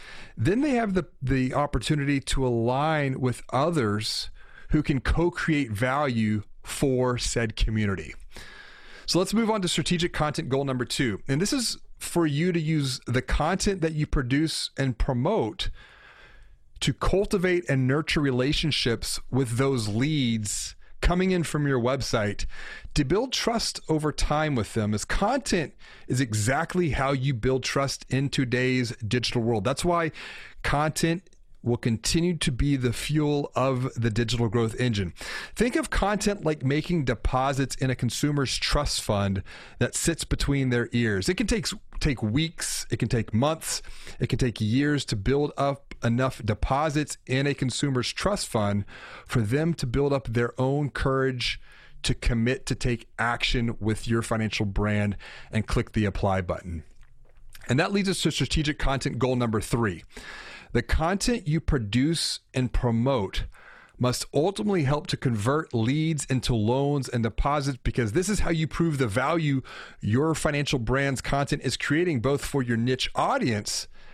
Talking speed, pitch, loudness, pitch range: 155 wpm, 135 Hz, -26 LUFS, 120-155 Hz